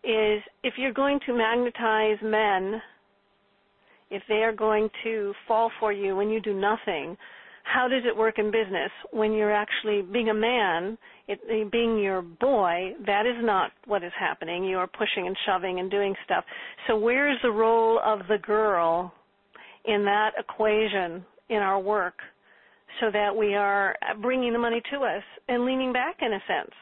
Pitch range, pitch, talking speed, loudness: 200-230 Hz, 215 Hz, 175 wpm, -26 LUFS